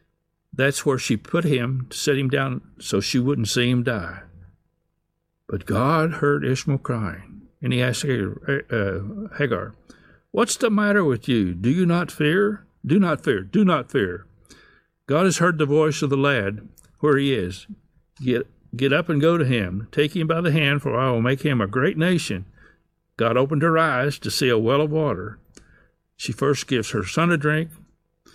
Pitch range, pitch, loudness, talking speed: 120-155 Hz, 140 Hz, -22 LUFS, 185 wpm